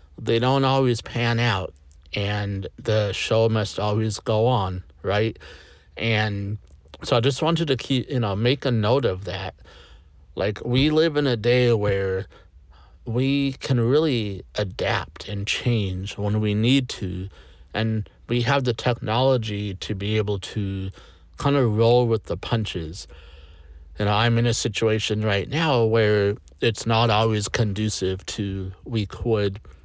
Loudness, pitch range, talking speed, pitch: -23 LUFS, 95-120 Hz, 150 wpm, 110 Hz